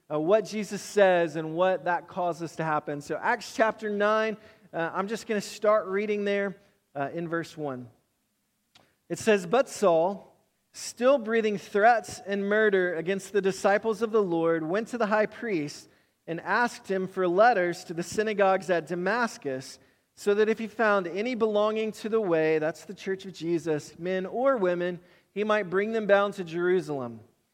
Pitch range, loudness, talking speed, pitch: 170-215 Hz, -27 LUFS, 175 wpm, 195 Hz